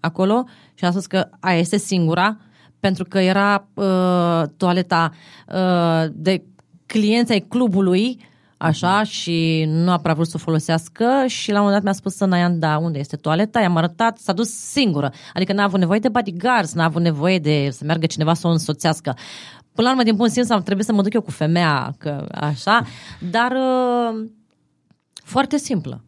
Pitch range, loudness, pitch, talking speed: 165-220 Hz, -19 LUFS, 185 Hz, 185 wpm